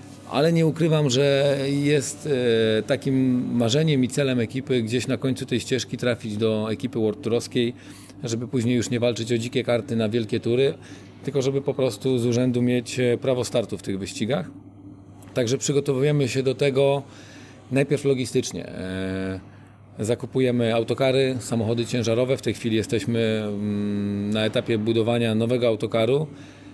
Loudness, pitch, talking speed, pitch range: -23 LUFS, 120 Hz, 140 wpm, 110-130 Hz